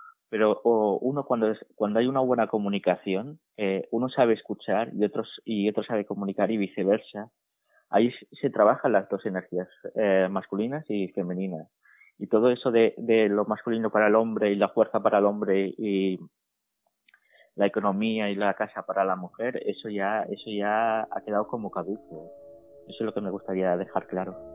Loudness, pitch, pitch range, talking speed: -26 LUFS, 105 Hz, 95-115 Hz, 175 wpm